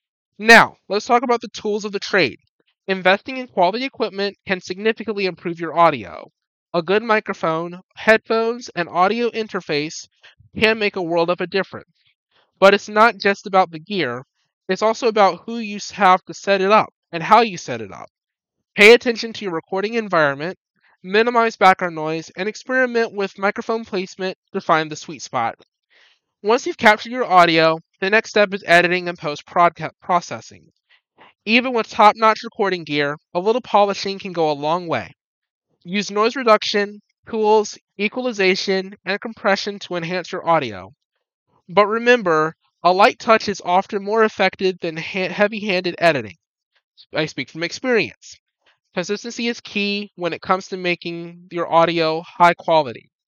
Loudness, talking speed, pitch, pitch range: -18 LUFS, 160 wpm, 190 Hz, 170-215 Hz